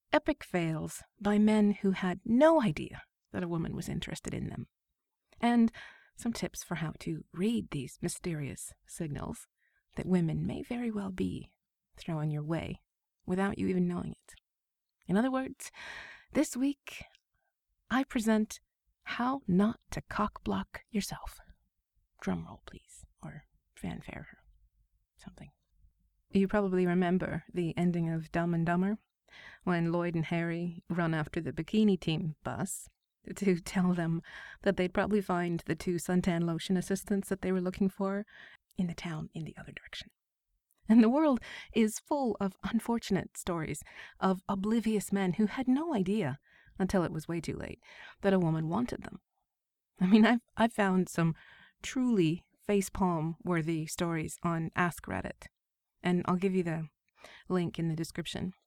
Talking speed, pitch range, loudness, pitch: 150 wpm, 170-215 Hz, -32 LUFS, 185 Hz